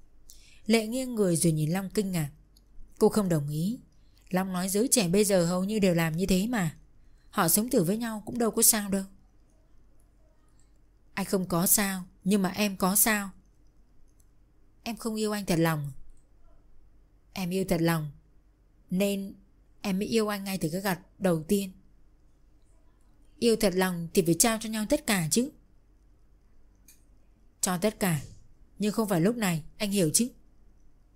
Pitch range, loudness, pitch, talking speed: 140-210 Hz, -27 LUFS, 185 Hz, 170 wpm